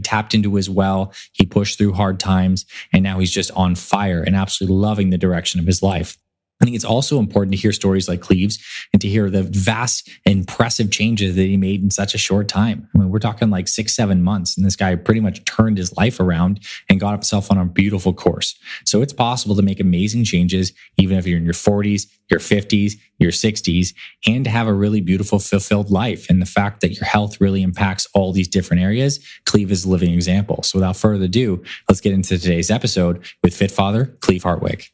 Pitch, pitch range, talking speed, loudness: 100 Hz, 95-105 Hz, 220 wpm, -18 LUFS